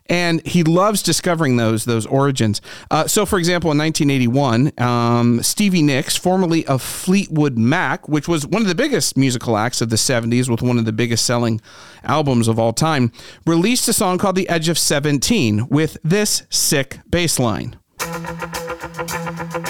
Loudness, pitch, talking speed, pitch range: -17 LUFS, 150 Hz, 165 wpm, 120-170 Hz